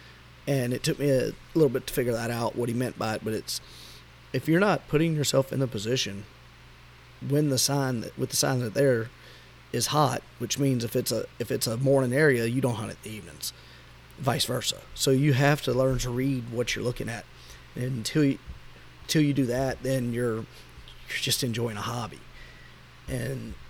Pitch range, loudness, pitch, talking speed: 110-135 Hz, -27 LUFS, 125 Hz, 205 wpm